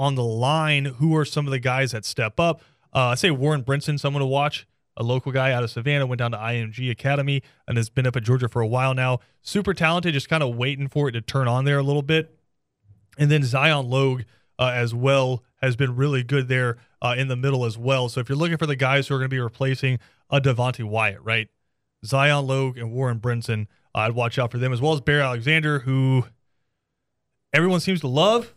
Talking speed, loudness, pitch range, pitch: 235 wpm, -22 LUFS, 125-145 Hz, 130 Hz